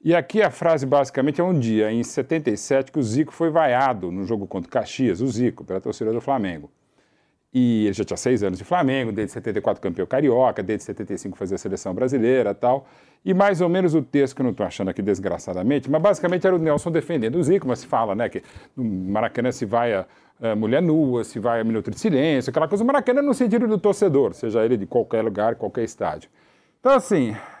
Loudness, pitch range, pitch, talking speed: -22 LUFS, 115-170 Hz, 135 Hz, 220 wpm